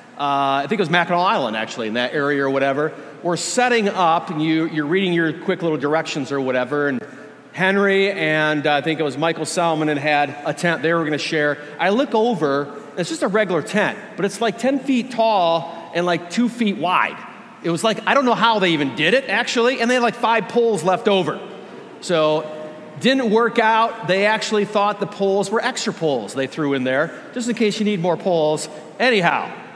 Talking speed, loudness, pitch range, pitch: 215 wpm, -19 LUFS, 155-220 Hz, 175 Hz